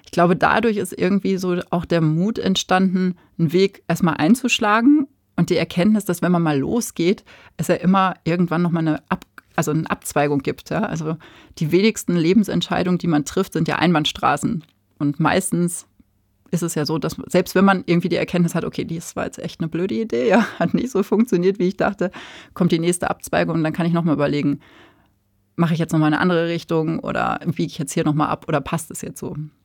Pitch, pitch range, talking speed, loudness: 170 Hz, 160-185 Hz, 215 wpm, -20 LUFS